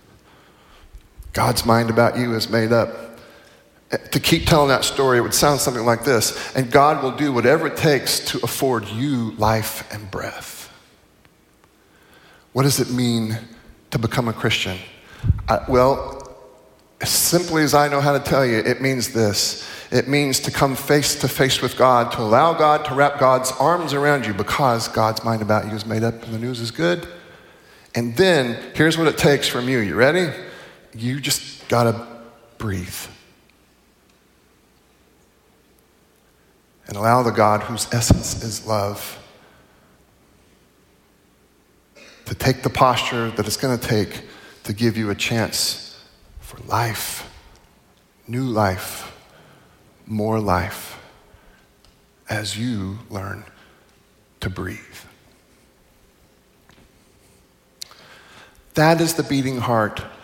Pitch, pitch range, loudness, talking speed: 120 Hz, 110-135 Hz, -19 LUFS, 135 wpm